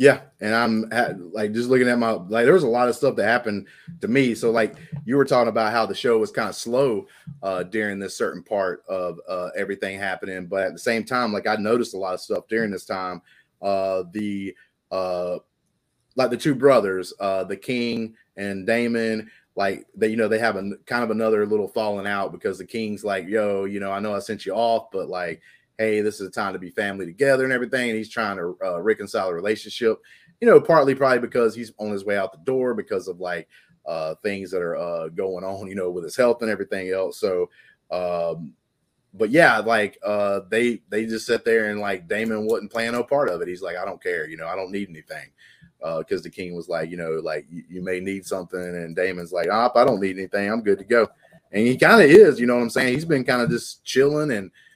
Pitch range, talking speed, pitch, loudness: 100-125 Hz, 240 wpm, 110 Hz, -22 LUFS